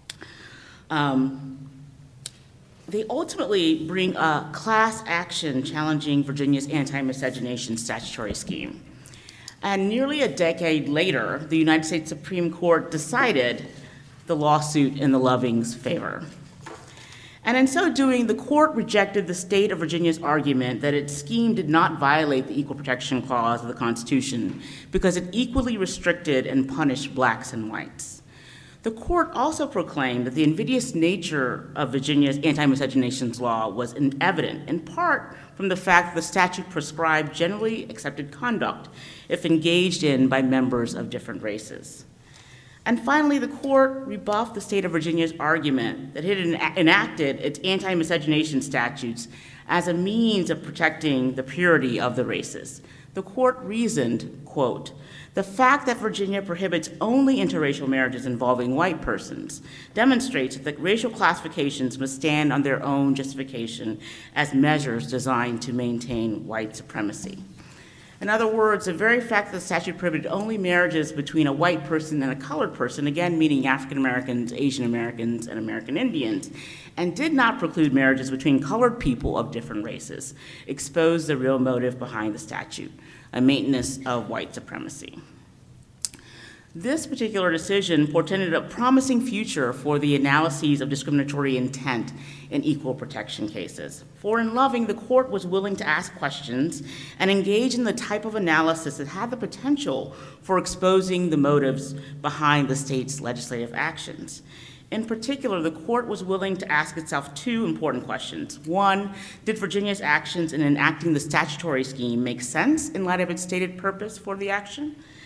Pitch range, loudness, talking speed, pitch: 135-195 Hz, -24 LUFS, 155 wpm, 155 Hz